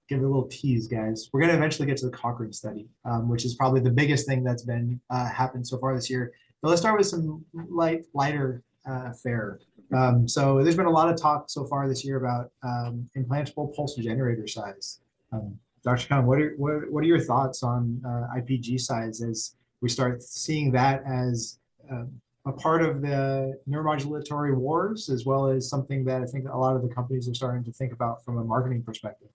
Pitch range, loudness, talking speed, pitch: 120-140 Hz, -27 LUFS, 215 wpm, 130 Hz